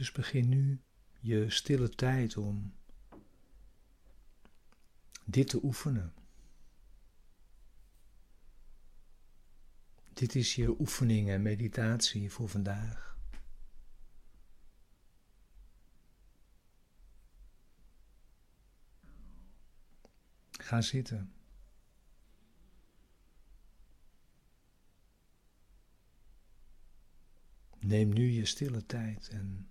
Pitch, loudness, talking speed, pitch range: 110 Hz, -33 LUFS, 55 wpm, 100-125 Hz